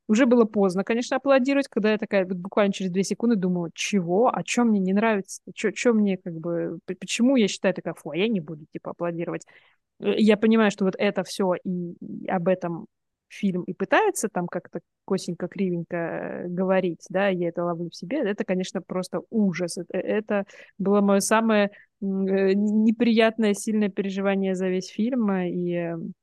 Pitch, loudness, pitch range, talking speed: 195 Hz, -24 LUFS, 180-215 Hz, 170 wpm